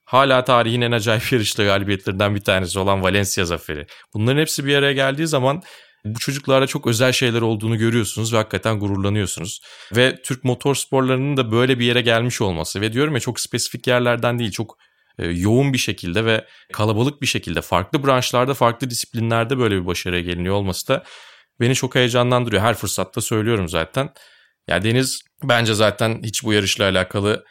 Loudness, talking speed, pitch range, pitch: -19 LUFS, 170 wpm, 105-130 Hz, 115 Hz